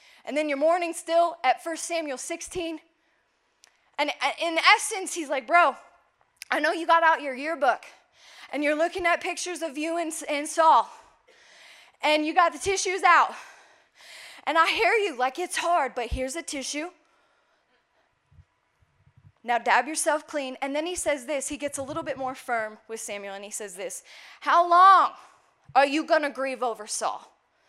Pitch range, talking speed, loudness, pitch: 280-340 Hz, 170 wpm, -25 LUFS, 320 Hz